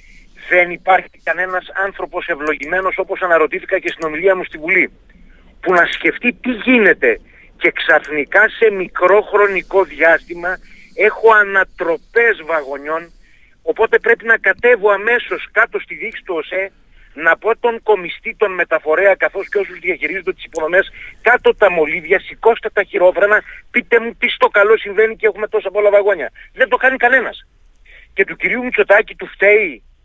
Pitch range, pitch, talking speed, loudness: 180-225 Hz, 200 Hz, 150 wpm, -15 LUFS